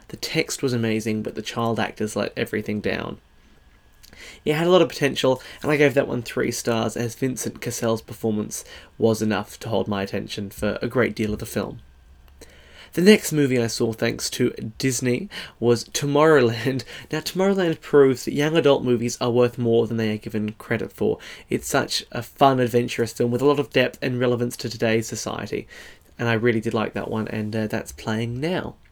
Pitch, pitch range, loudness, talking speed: 115 Hz, 110-135 Hz, -23 LUFS, 195 wpm